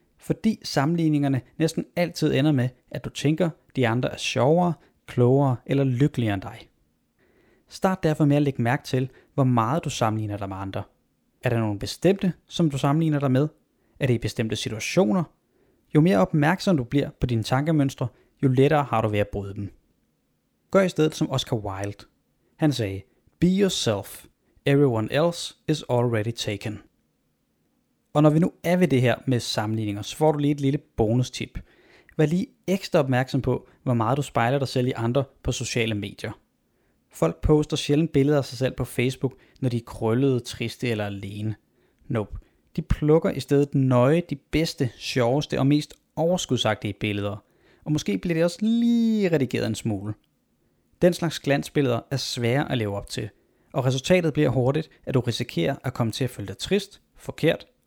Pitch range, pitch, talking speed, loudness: 115-155 Hz, 135 Hz, 180 wpm, -24 LUFS